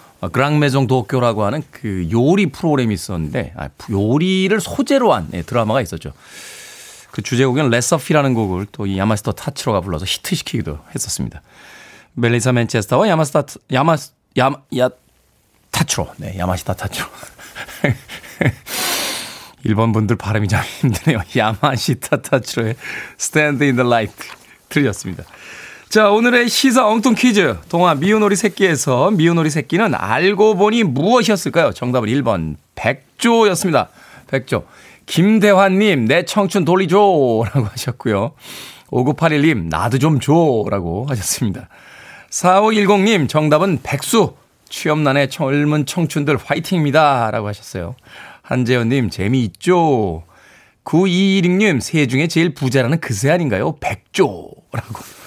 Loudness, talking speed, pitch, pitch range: -16 LUFS, 290 characters per minute, 140 Hz, 115-180 Hz